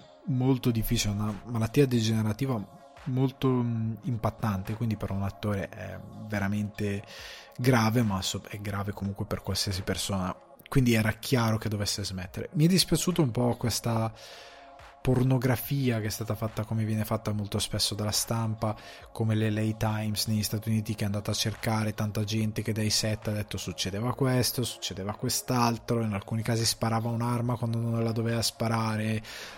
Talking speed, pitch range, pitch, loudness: 160 wpm, 105-120 Hz, 110 Hz, -29 LUFS